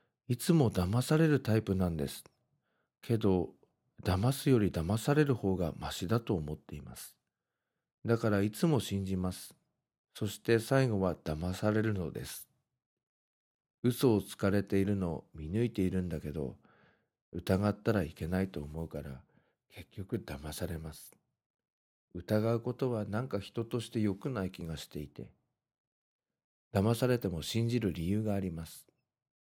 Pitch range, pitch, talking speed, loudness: 85-115 Hz, 100 Hz, 275 characters per minute, -33 LUFS